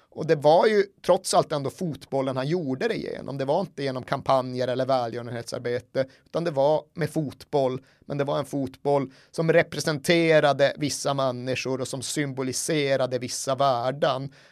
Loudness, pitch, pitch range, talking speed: -25 LUFS, 140 Hz, 130-155 Hz, 155 wpm